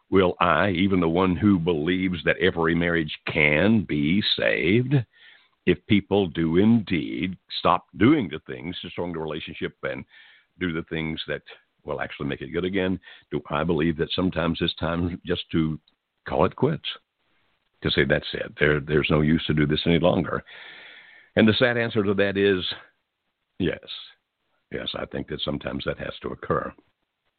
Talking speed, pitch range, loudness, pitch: 170 wpm, 80-95 Hz, -24 LUFS, 85 Hz